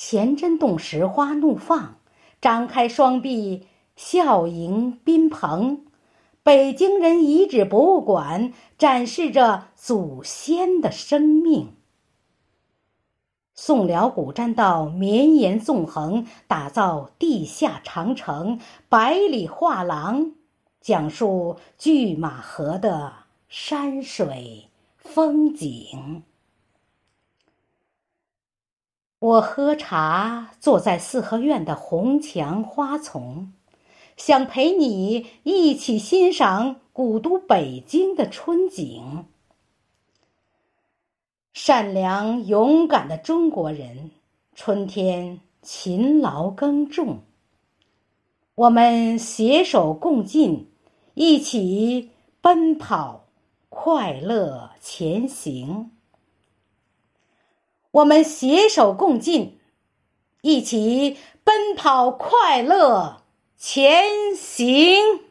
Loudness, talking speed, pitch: -20 LUFS, 120 characters per minute, 245 Hz